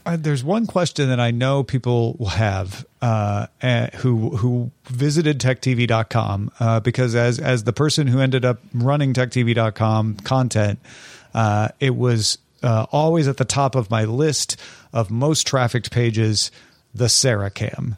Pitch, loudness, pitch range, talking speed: 125 Hz, -20 LUFS, 115-135 Hz, 145 wpm